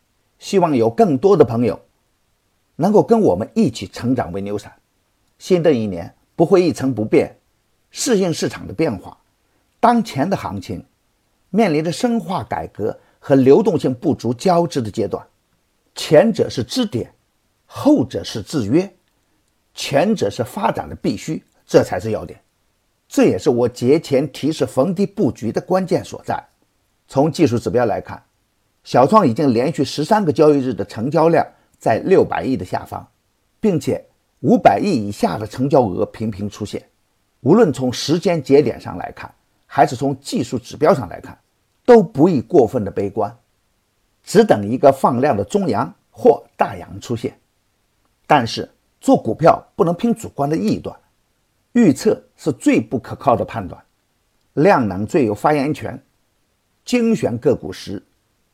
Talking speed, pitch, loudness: 230 characters per minute, 135 Hz, -17 LUFS